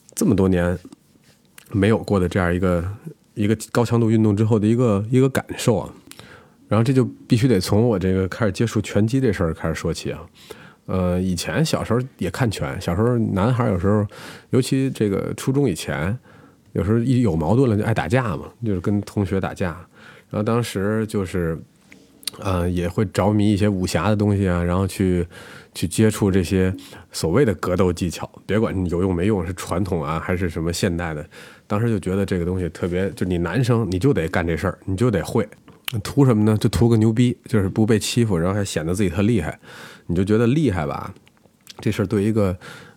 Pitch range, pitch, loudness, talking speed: 90-115 Hz, 105 Hz, -21 LUFS, 300 characters per minute